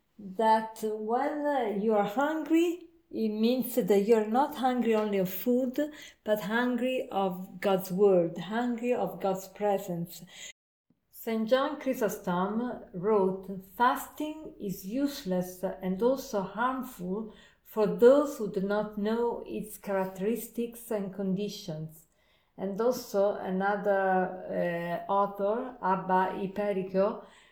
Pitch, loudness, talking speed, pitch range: 210 Hz, -30 LUFS, 110 wpm, 195-245 Hz